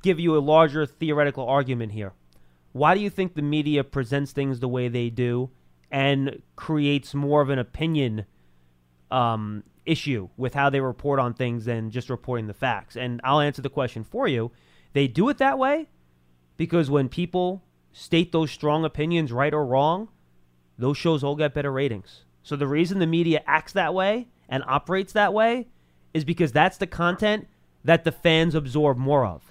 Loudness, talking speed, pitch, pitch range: -24 LUFS, 180 wpm, 140 Hz, 125-165 Hz